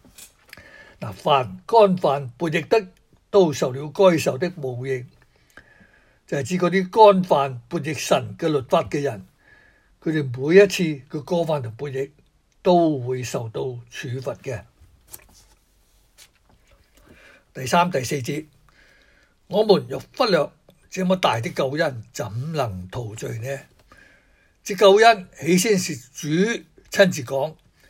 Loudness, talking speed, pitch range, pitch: -21 LUFS, 170 characters per minute, 135-185 Hz, 155 Hz